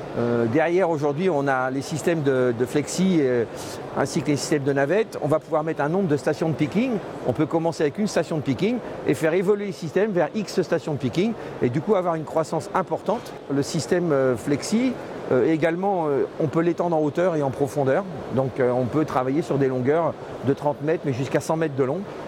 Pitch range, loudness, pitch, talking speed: 140-180 Hz, -23 LUFS, 155 Hz, 225 wpm